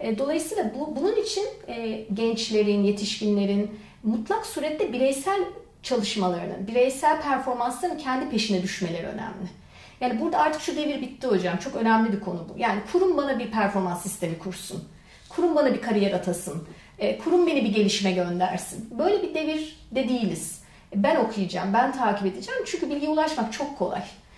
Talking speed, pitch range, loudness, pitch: 155 wpm, 195-300 Hz, -26 LUFS, 230 Hz